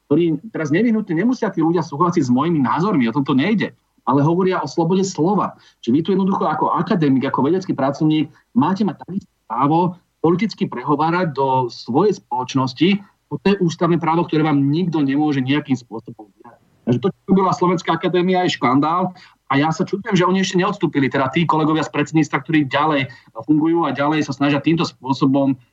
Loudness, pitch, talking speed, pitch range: -18 LUFS, 160 Hz, 180 wpm, 140-180 Hz